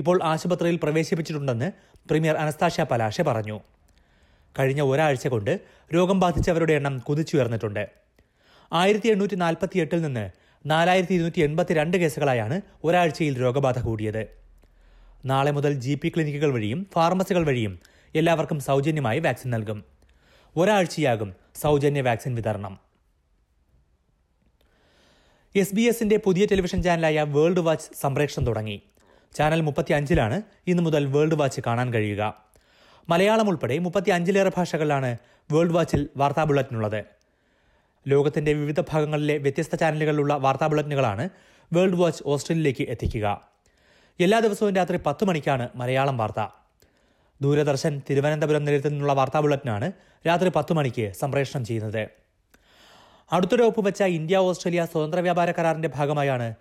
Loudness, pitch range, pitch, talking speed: -24 LUFS, 125-170 Hz, 150 Hz, 110 wpm